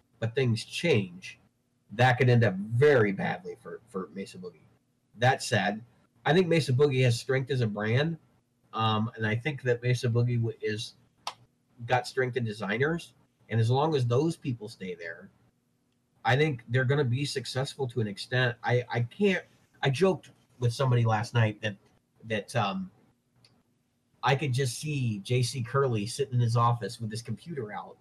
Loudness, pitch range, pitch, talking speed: -28 LUFS, 110-135 Hz, 120 Hz, 170 wpm